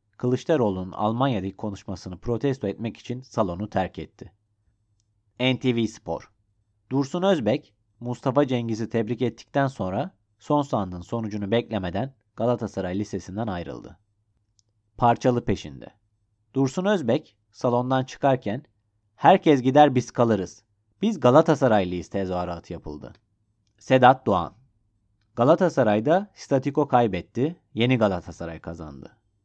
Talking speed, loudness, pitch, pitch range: 95 wpm, -24 LUFS, 110 Hz, 100-130 Hz